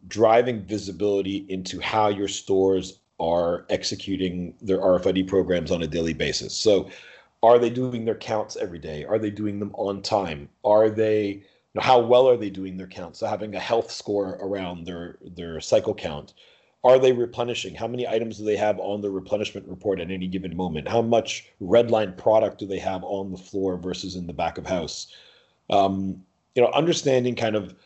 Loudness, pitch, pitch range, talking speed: -24 LUFS, 100 Hz, 95-110 Hz, 190 wpm